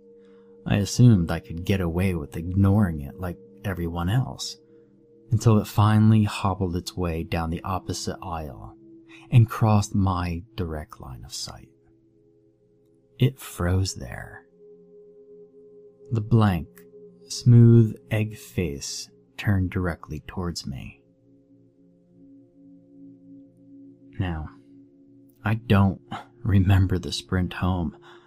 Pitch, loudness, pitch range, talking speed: 105 Hz, -24 LUFS, 90-135 Hz, 100 wpm